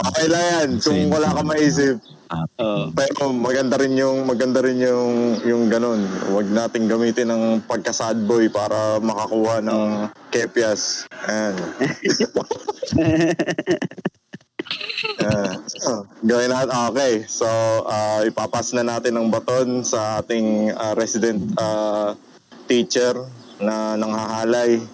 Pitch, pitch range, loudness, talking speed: 115 Hz, 110-125 Hz, -20 LUFS, 105 wpm